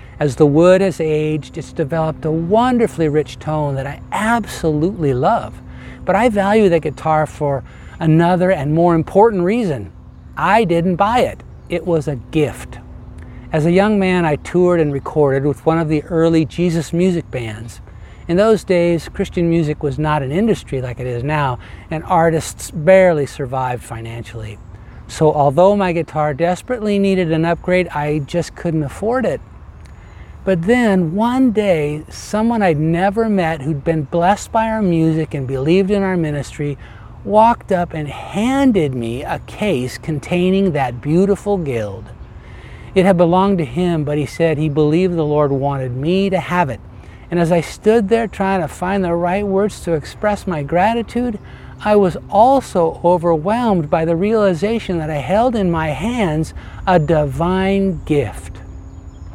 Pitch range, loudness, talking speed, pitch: 140-190 Hz, -16 LUFS, 160 wpm, 165 Hz